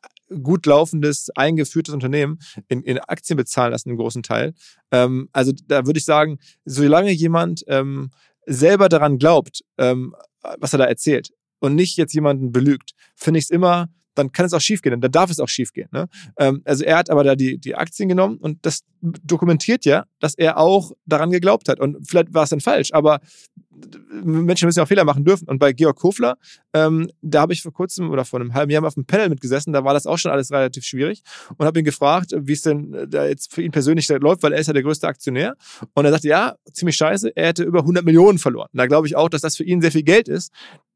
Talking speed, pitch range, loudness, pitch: 230 wpm, 140-170 Hz, -18 LUFS, 155 Hz